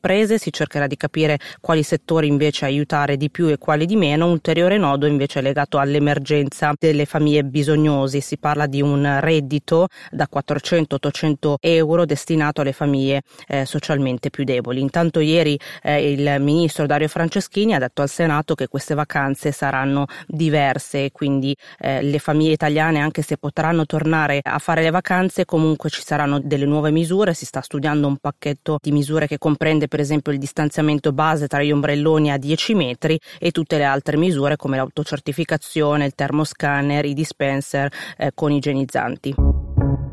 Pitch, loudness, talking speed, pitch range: 150 Hz, -19 LUFS, 165 wpm, 140-160 Hz